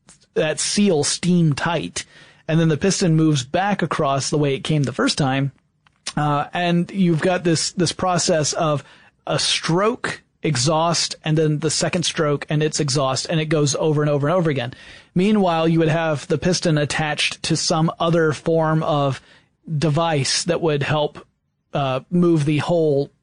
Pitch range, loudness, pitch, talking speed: 150-170 Hz, -20 LUFS, 160 Hz, 170 wpm